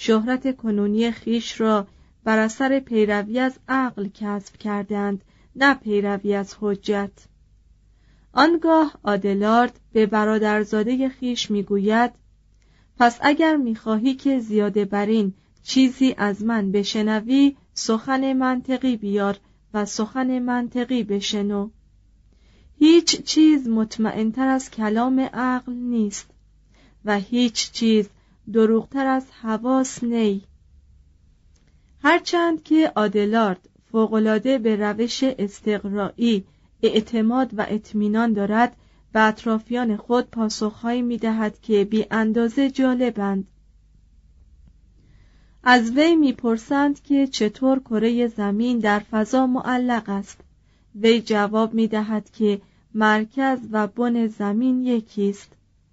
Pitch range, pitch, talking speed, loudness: 205-250 Hz, 220 Hz, 105 wpm, -21 LUFS